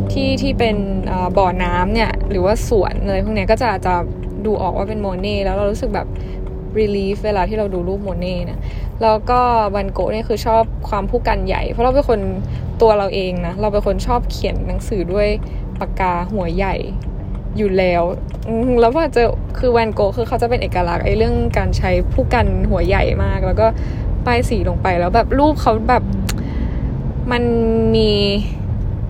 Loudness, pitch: -18 LUFS, 190 Hz